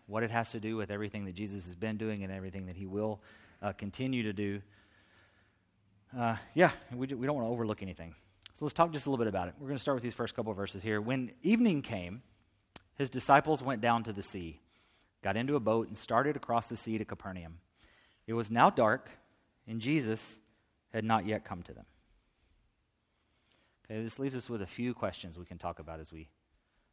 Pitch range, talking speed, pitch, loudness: 95-115 Hz, 220 wpm, 110 Hz, -34 LUFS